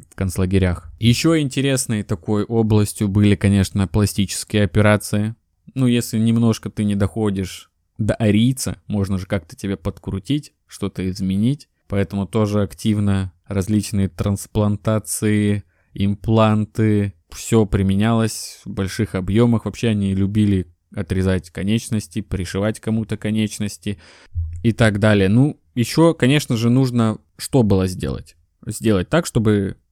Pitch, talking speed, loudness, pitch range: 105 Hz, 115 wpm, -19 LUFS, 95-110 Hz